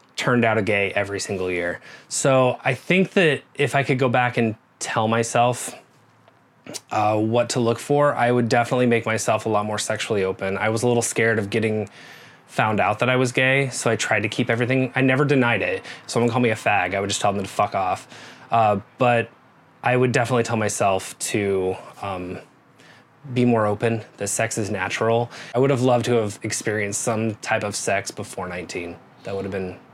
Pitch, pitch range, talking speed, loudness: 115 Hz, 105-125 Hz, 205 wpm, -21 LUFS